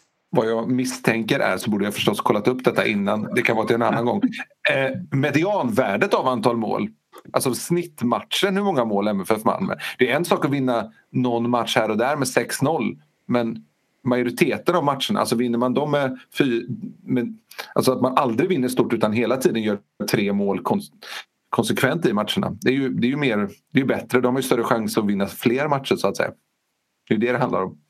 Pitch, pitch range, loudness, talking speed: 125 Hz, 115-135 Hz, -22 LUFS, 215 wpm